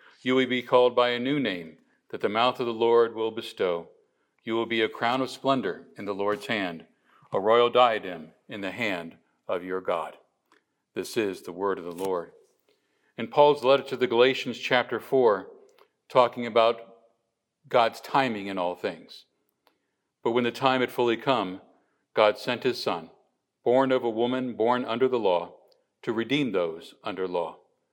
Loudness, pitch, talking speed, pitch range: -26 LUFS, 120 Hz, 175 wpm, 115-130 Hz